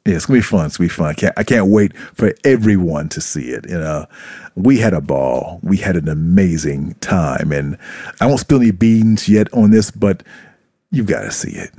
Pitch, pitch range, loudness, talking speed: 100 Hz, 80-110 Hz, -15 LUFS, 225 wpm